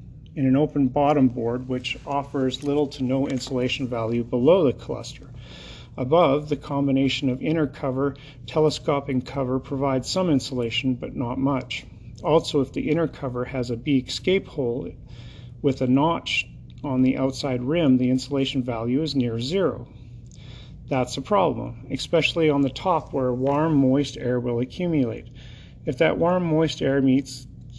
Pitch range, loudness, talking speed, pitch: 125-145 Hz, -23 LUFS, 155 wpm, 130 Hz